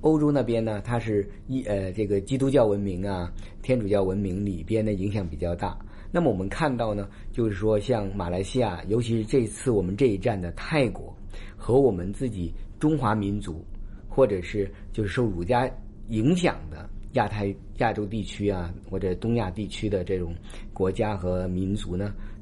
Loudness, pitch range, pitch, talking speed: -27 LUFS, 95-115 Hz, 100 Hz, 270 characters per minute